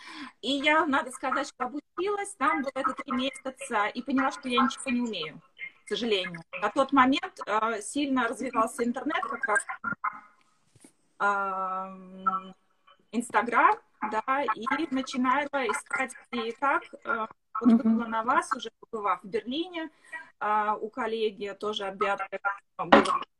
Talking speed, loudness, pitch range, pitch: 135 wpm, -28 LUFS, 210-270 Hz, 235 Hz